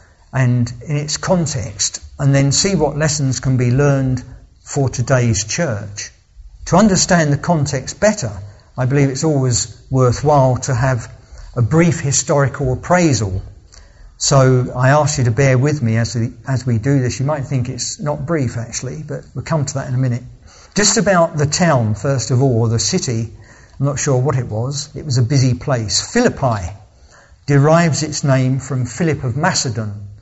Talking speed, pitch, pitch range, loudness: 175 wpm, 130 Hz, 120-145 Hz, -16 LUFS